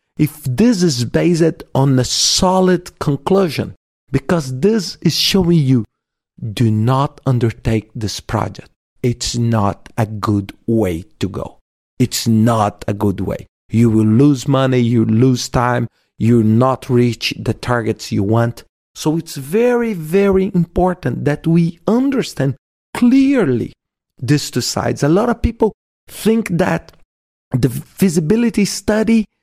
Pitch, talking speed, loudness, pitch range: 135 Hz, 135 wpm, -16 LUFS, 115-180 Hz